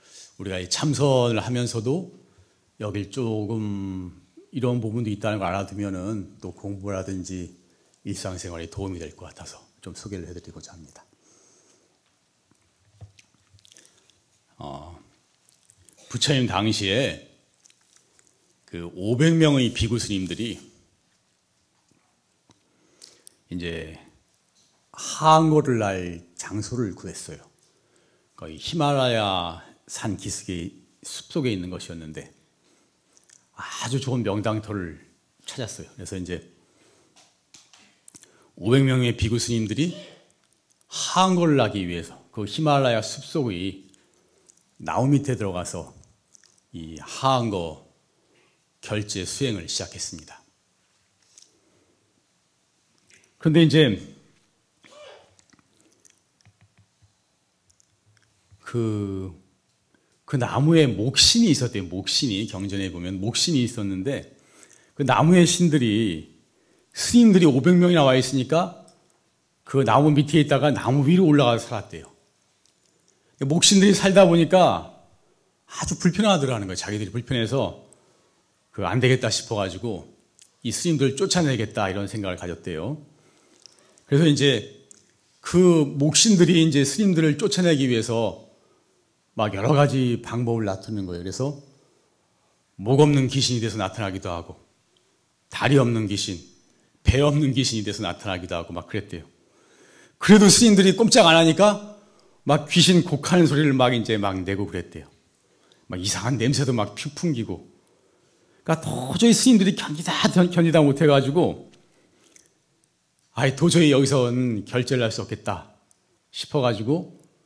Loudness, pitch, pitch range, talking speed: -21 LUFS, 115 Hz, 95-145 Hz, 240 characters per minute